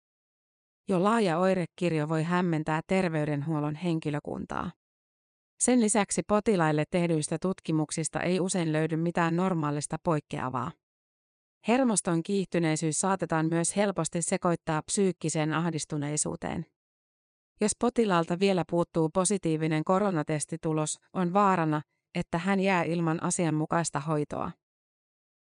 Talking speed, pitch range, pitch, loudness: 95 wpm, 155-185 Hz, 170 Hz, -28 LUFS